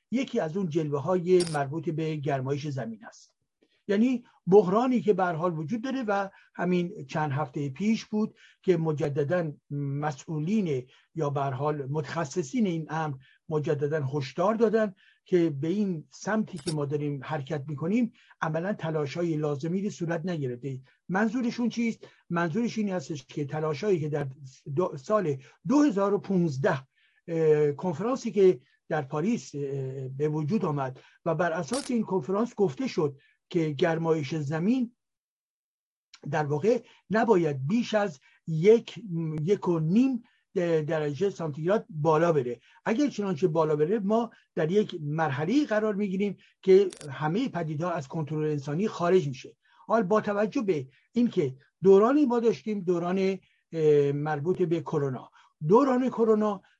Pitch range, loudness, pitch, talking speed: 155-210 Hz, -28 LUFS, 175 Hz, 130 wpm